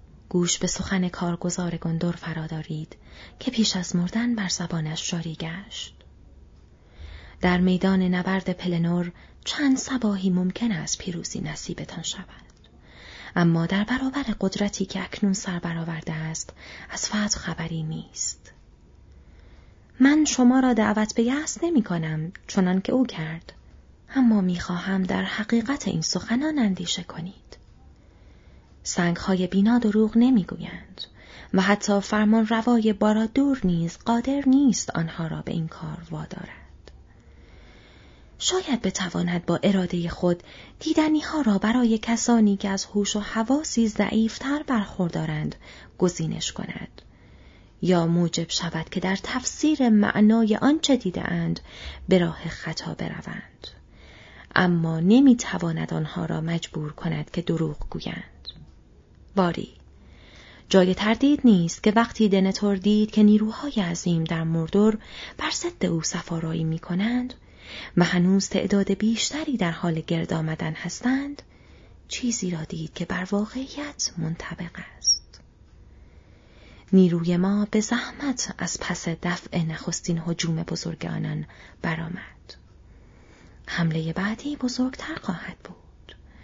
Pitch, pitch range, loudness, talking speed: 185 Hz, 165-220 Hz, -24 LUFS, 120 wpm